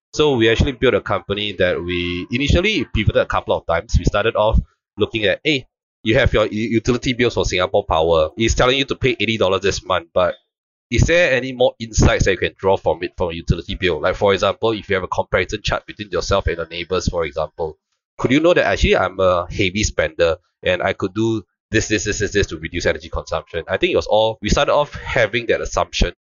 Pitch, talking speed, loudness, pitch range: 110 Hz, 235 wpm, -18 LUFS, 100-115 Hz